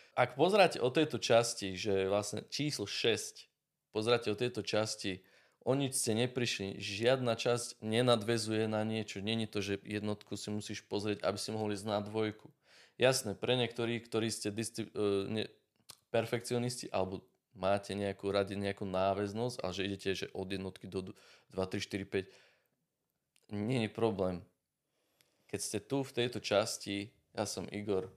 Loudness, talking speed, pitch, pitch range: -35 LUFS, 155 wpm, 105 Hz, 100-115 Hz